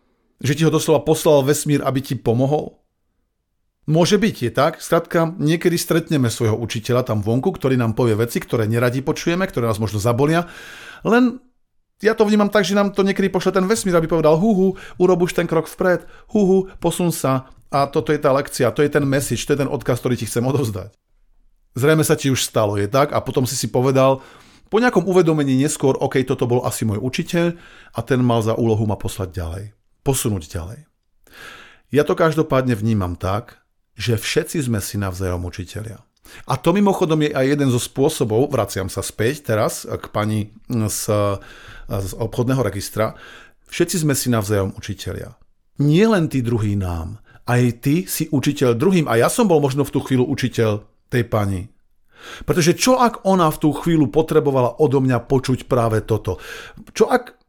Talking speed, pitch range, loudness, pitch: 180 wpm, 110-160 Hz, -19 LUFS, 135 Hz